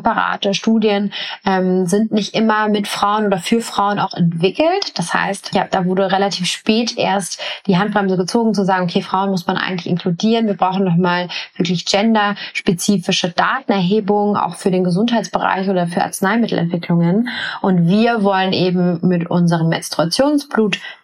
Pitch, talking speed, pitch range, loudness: 195 Hz, 150 wpm, 185-210 Hz, -16 LUFS